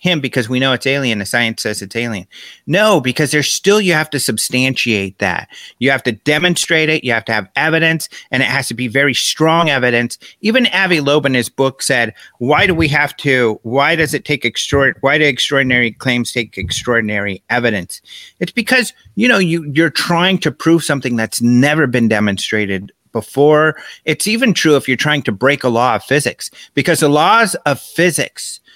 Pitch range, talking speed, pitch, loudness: 120-160 Hz, 195 wpm, 140 Hz, -14 LUFS